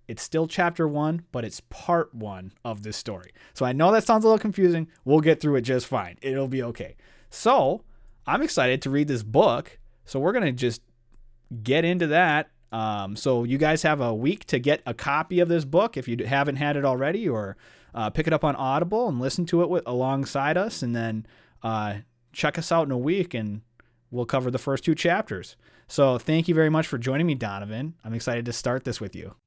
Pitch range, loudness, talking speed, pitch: 115-160 Hz, -25 LUFS, 220 wpm, 135 Hz